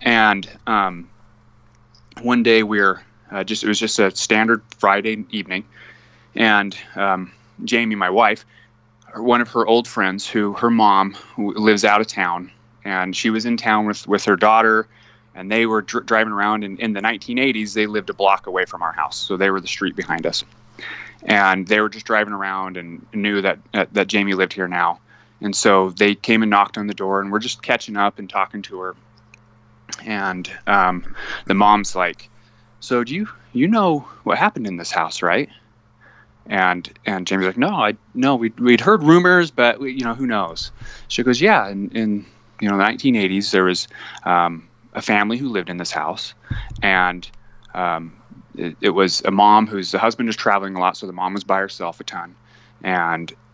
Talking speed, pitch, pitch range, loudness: 190 wpm, 105 Hz, 95-115 Hz, -18 LUFS